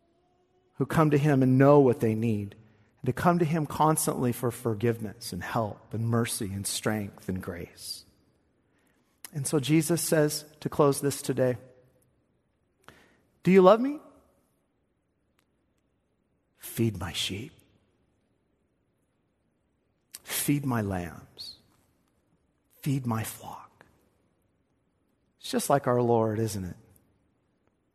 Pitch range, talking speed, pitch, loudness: 110-145 Hz, 115 wpm, 125 Hz, -27 LUFS